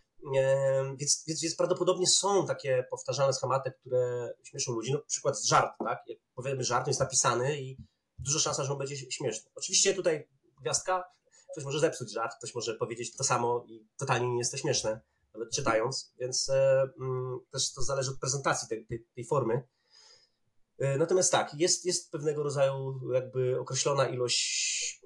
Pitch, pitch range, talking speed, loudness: 135 Hz, 130-180 Hz, 170 wpm, -30 LUFS